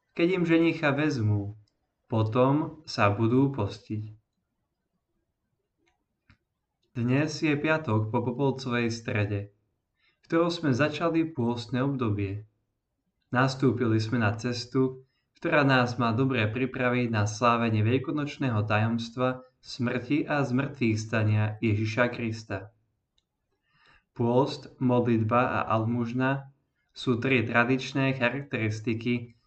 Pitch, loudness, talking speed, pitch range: 125 Hz, -27 LUFS, 95 wpm, 110-135 Hz